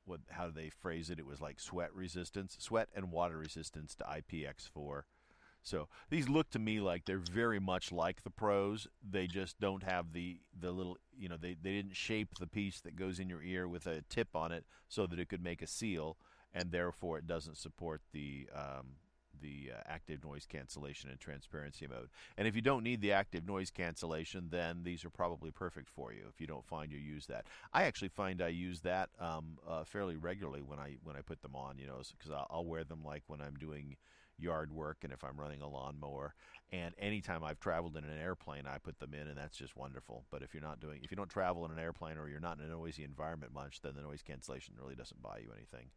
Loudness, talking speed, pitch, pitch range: -43 LUFS, 230 wpm, 85 Hz, 75-90 Hz